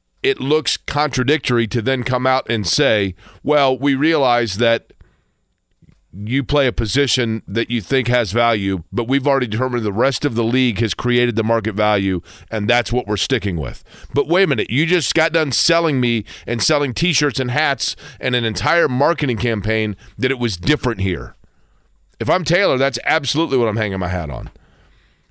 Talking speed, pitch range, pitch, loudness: 185 wpm, 110-140 Hz, 120 Hz, -18 LUFS